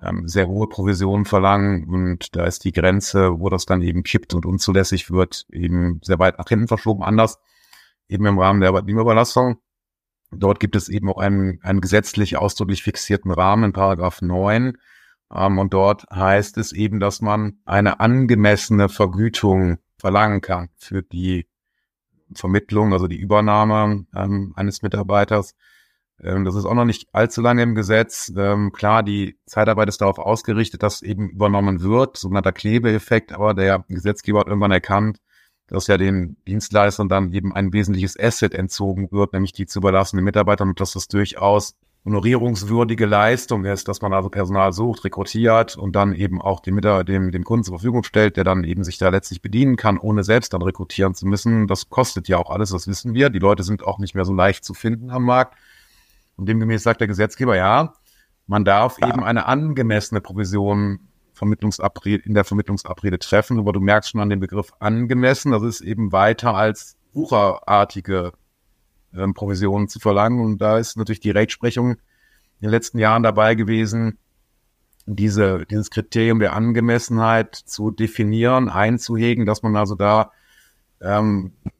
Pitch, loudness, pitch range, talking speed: 100 Hz, -19 LUFS, 95-110 Hz, 165 wpm